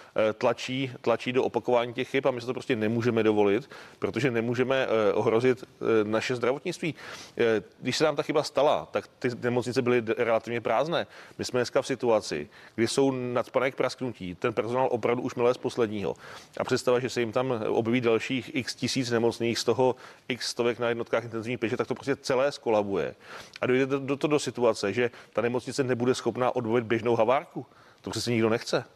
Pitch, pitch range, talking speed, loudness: 125 Hz, 115-130 Hz, 185 wpm, -27 LUFS